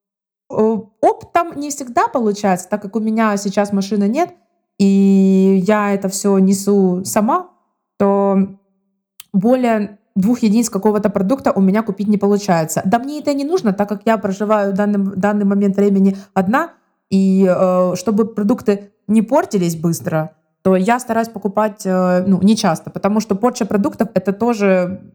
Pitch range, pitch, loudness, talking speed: 195-220 Hz, 205 Hz, -16 LUFS, 150 wpm